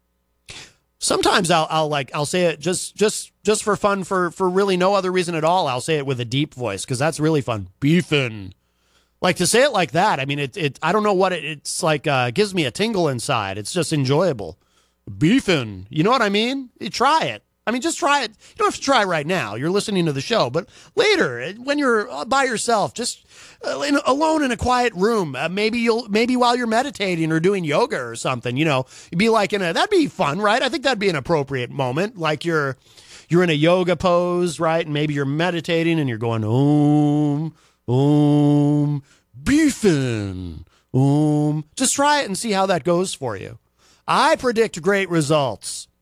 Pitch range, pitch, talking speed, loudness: 145-210 Hz, 170 Hz, 205 wpm, -20 LUFS